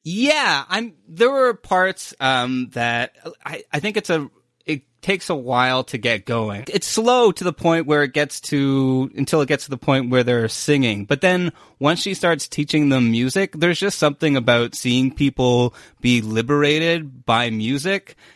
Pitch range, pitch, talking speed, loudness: 125-175 Hz, 145 Hz, 180 wpm, -19 LUFS